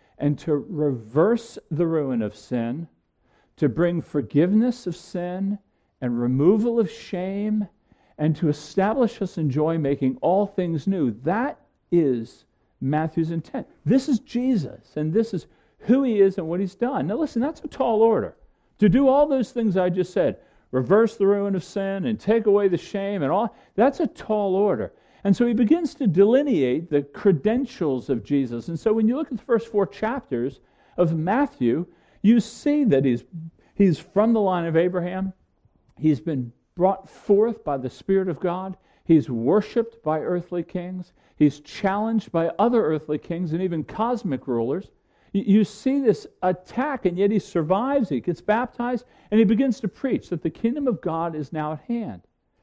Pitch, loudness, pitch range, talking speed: 190 Hz, -23 LUFS, 160-225 Hz, 175 wpm